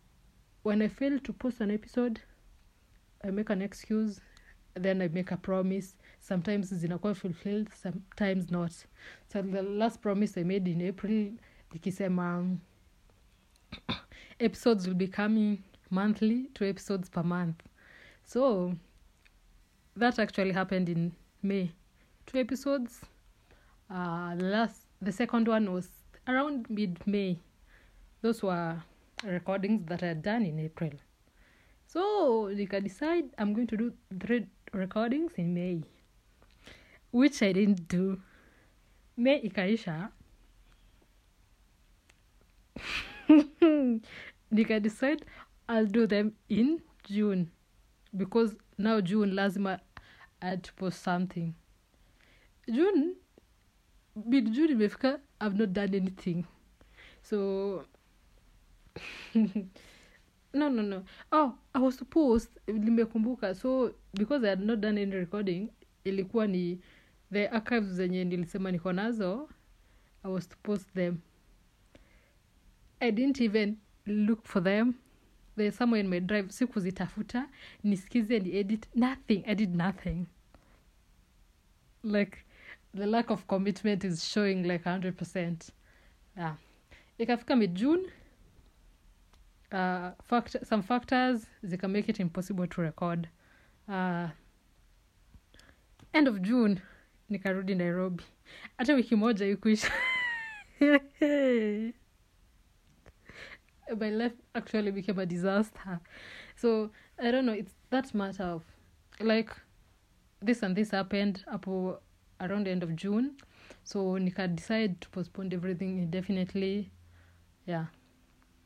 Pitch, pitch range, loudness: 200 Hz, 185-225 Hz, -31 LUFS